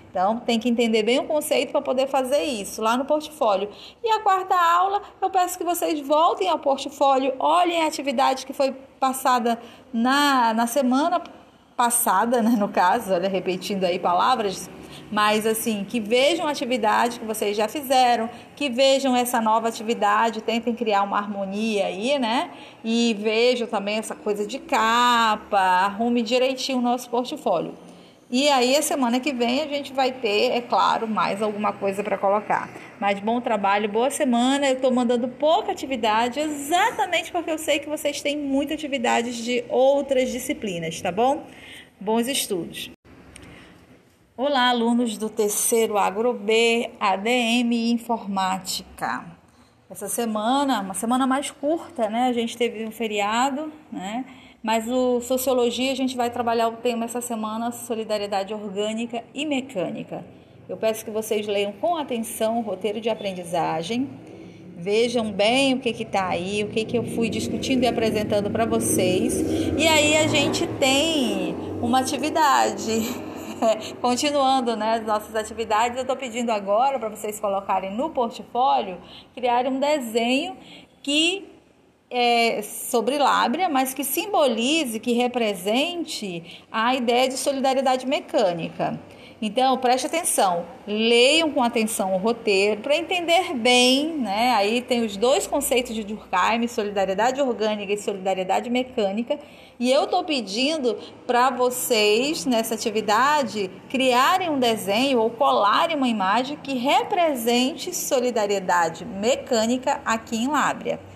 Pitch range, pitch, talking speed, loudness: 220-275 Hz, 245 Hz, 145 wpm, -22 LUFS